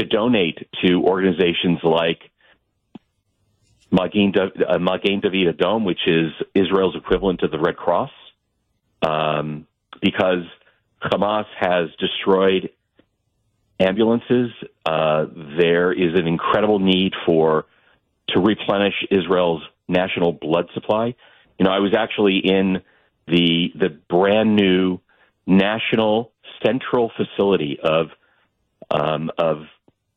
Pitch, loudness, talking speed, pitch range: 95 Hz, -19 LUFS, 100 wpm, 85-105 Hz